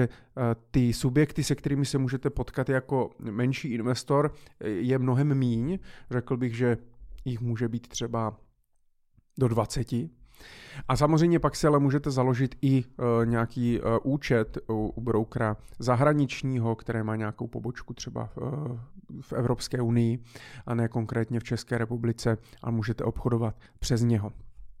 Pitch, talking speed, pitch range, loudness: 120 Hz, 130 wpm, 115-135 Hz, -28 LUFS